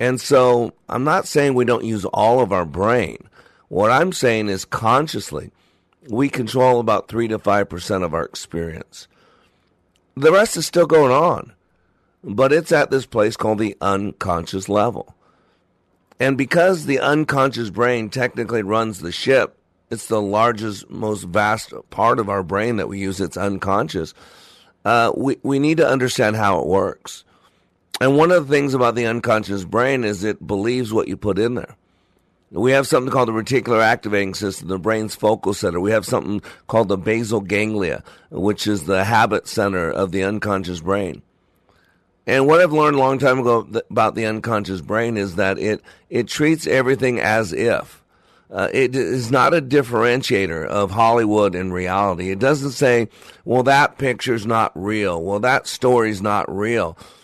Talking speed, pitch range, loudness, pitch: 170 wpm, 100-130 Hz, -19 LUFS, 110 Hz